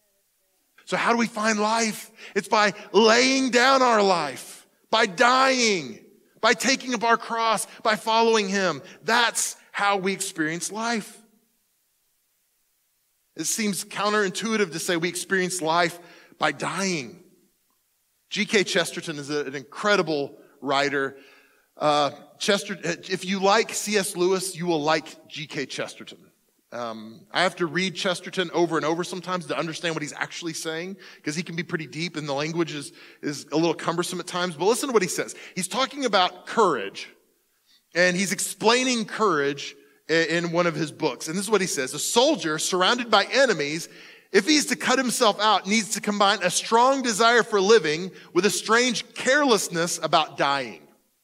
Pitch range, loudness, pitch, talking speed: 165-220 Hz, -23 LUFS, 190 Hz, 160 wpm